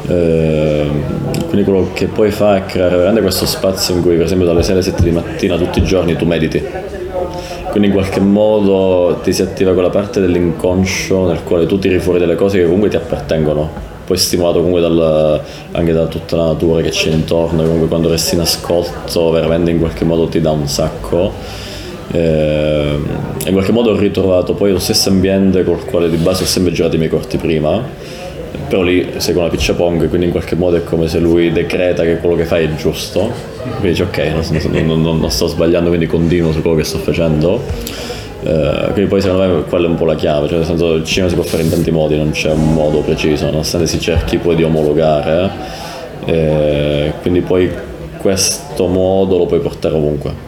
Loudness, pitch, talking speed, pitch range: -13 LUFS, 85 Hz, 205 wpm, 80-90 Hz